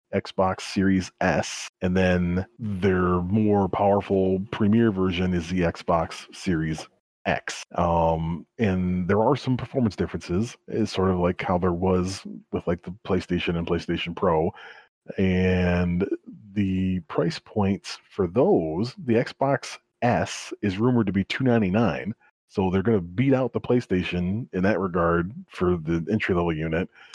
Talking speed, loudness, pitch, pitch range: 145 wpm, -25 LUFS, 95 Hz, 90-105 Hz